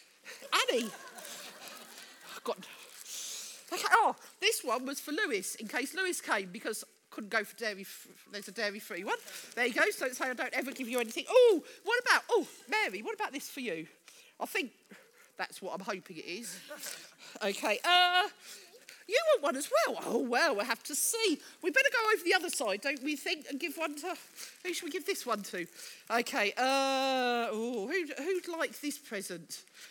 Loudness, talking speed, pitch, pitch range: -32 LUFS, 195 wpm, 300 Hz, 245-385 Hz